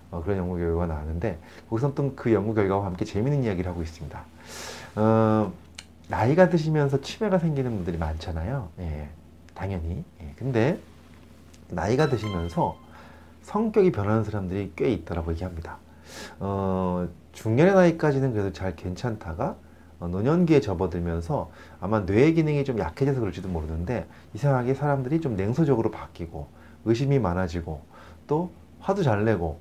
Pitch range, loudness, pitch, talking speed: 85-130 Hz, -26 LUFS, 95 Hz, 345 characters per minute